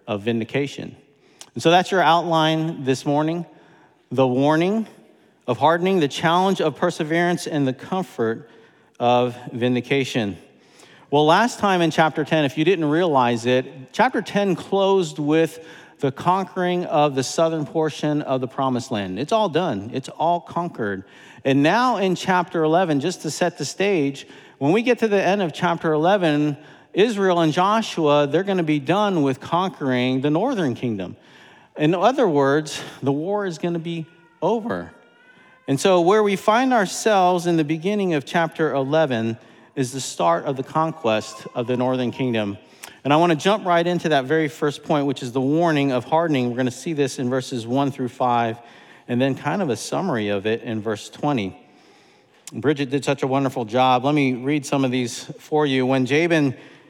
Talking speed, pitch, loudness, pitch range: 180 wpm, 150 Hz, -21 LUFS, 130-170 Hz